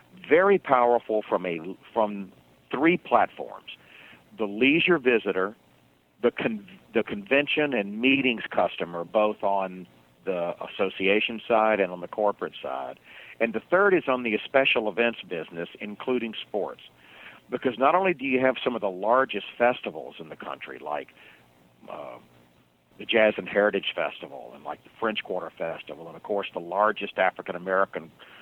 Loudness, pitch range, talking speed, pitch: -25 LUFS, 85-125 Hz, 150 wpm, 105 Hz